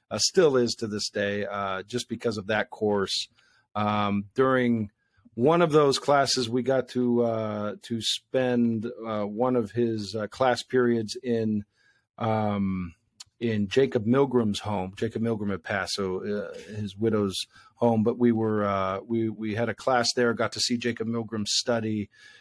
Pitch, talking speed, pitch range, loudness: 115 Hz, 165 wpm, 105-120 Hz, -26 LUFS